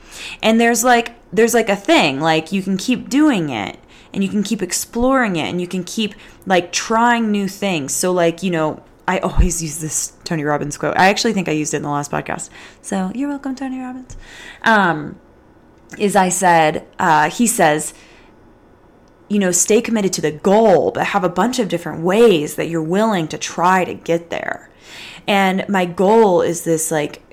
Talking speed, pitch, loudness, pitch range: 195 wpm, 185 Hz, -17 LUFS, 165-220 Hz